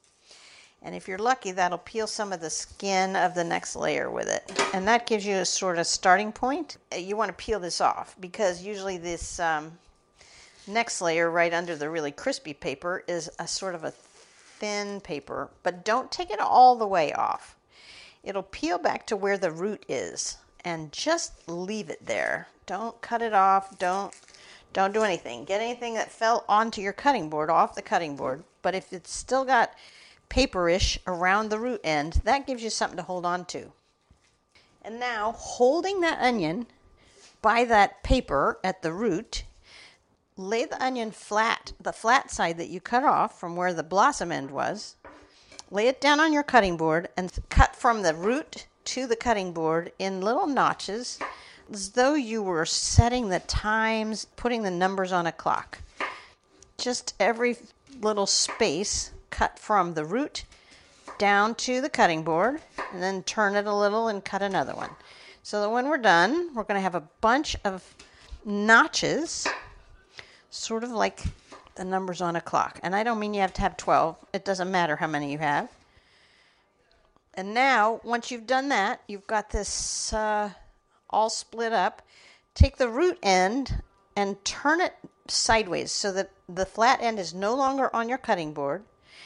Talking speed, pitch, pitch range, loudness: 175 wpm, 205 Hz, 185-235 Hz, -26 LUFS